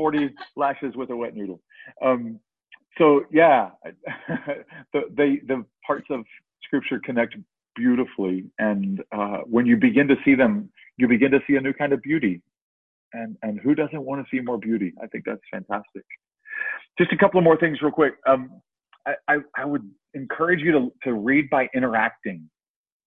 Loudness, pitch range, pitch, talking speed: -22 LUFS, 115-150 Hz, 135 Hz, 175 wpm